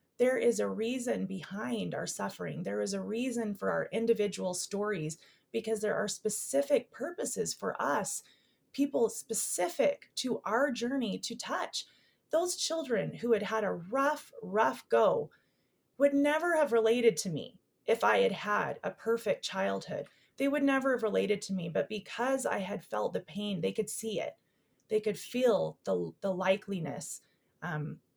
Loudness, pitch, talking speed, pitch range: -32 LUFS, 220 Hz, 160 wpm, 195-250 Hz